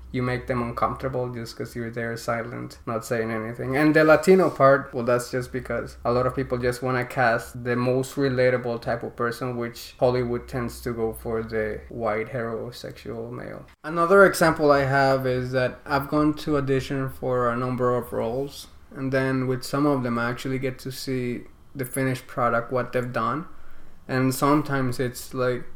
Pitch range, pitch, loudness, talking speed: 120-135 Hz, 125 Hz, -24 LUFS, 185 wpm